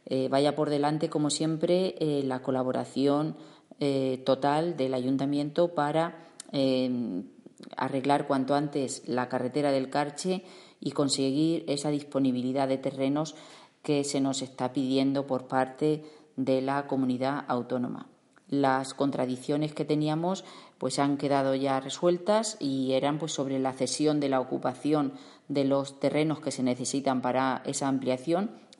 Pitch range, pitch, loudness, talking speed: 130-150 Hz, 140 Hz, -29 LUFS, 140 wpm